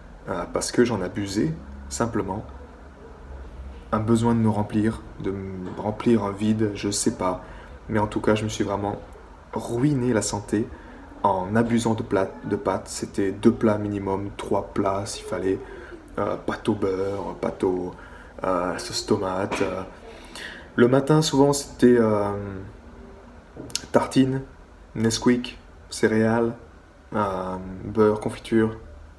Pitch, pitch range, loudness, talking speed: 100 Hz, 90-115 Hz, -24 LUFS, 135 wpm